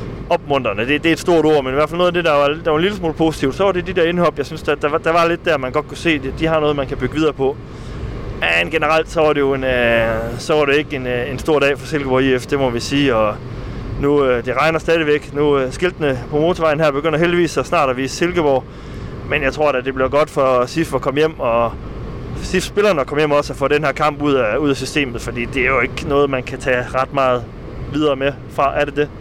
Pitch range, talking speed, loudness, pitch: 130-155 Hz, 275 wpm, -17 LUFS, 140 Hz